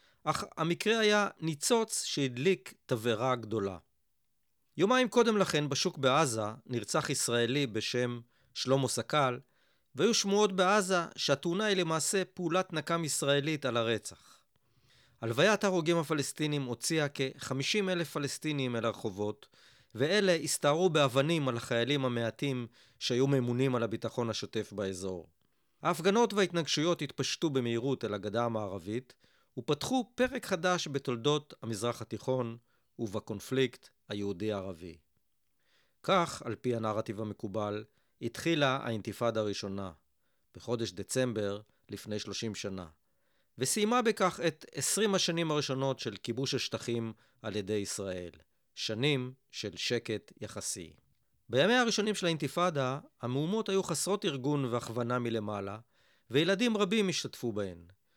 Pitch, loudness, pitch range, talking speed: 130 Hz, -32 LUFS, 110-165 Hz, 110 wpm